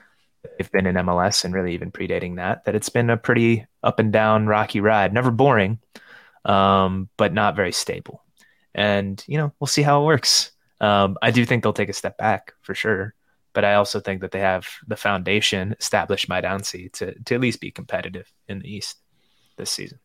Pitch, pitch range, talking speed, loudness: 105 Hz, 95-115 Hz, 205 wpm, -21 LUFS